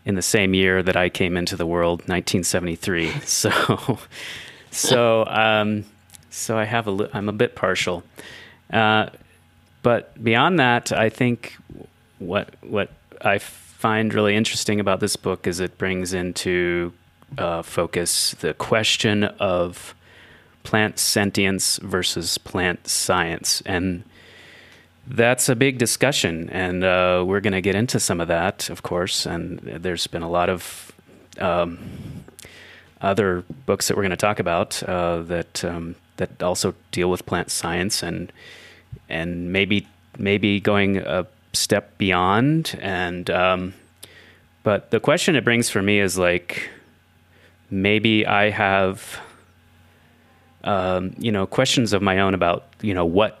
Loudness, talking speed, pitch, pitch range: -21 LUFS, 145 wpm, 95 Hz, 85-105 Hz